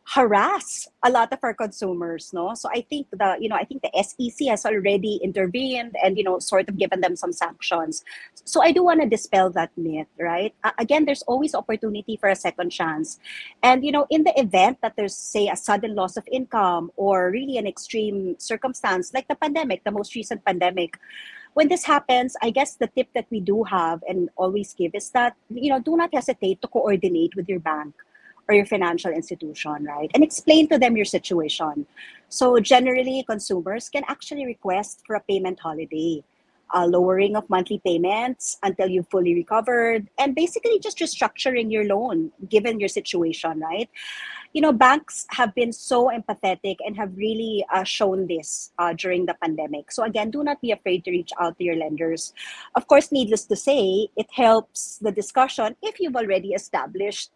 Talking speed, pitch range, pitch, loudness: 190 wpm, 185-255 Hz, 215 Hz, -22 LUFS